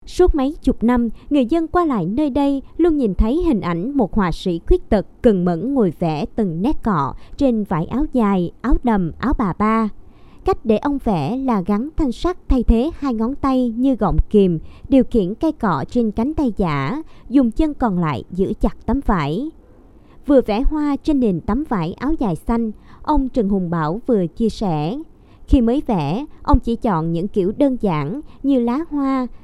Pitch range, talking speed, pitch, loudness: 205-280 Hz, 200 wpm, 235 Hz, -19 LUFS